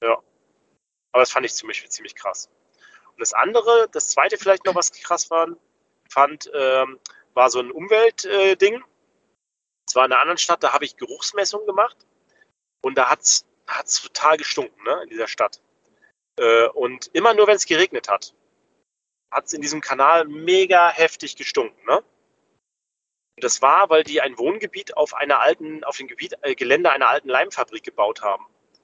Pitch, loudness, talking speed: 190 Hz, -19 LUFS, 180 wpm